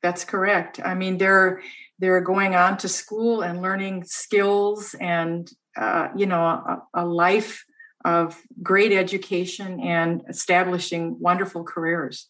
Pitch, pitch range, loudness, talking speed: 185 Hz, 175-195 Hz, -22 LUFS, 130 wpm